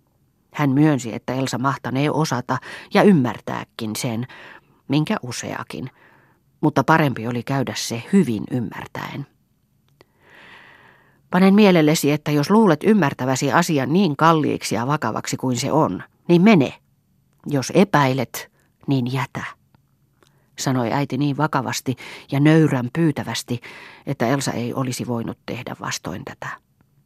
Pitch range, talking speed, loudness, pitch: 125-155 Hz, 120 wpm, -20 LUFS, 140 Hz